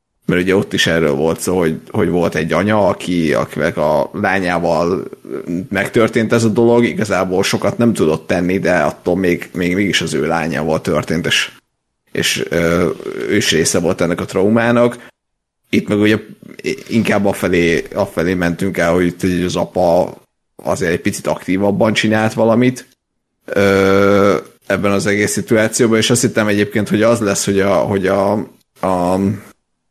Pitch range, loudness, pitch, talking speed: 90-110 Hz, -15 LUFS, 100 Hz, 155 wpm